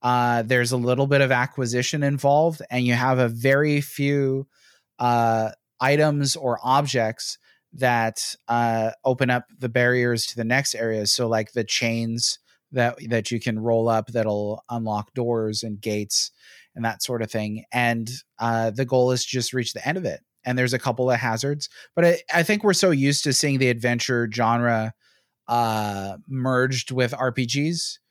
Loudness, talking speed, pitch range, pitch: -23 LUFS, 175 wpm, 115-135 Hz, 125 Hz